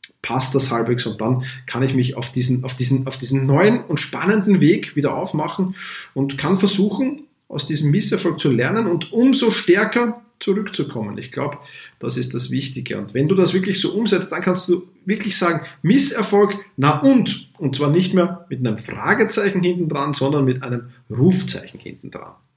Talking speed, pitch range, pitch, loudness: 180 wpm, 135-200 Hz, 165 Hz, -19 LUFS